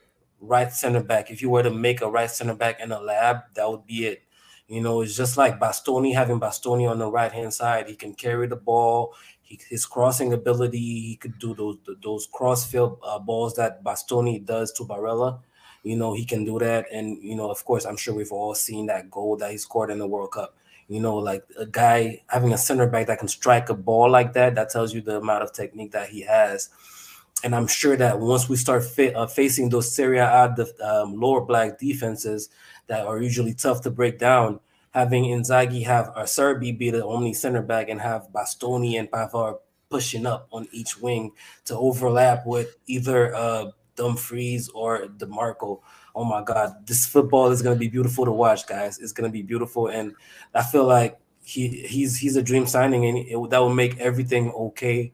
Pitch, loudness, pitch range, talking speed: 120 Hz, -23 LUFS, 110-125 Hz, 210 wpm